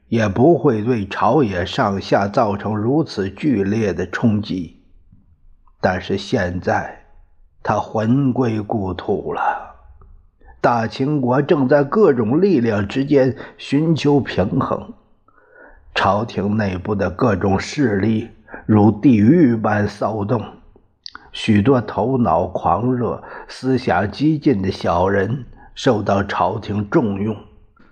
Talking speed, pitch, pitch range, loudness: 165 characters per minute, 110 Hz, 100-130 Hz, -18 LUFS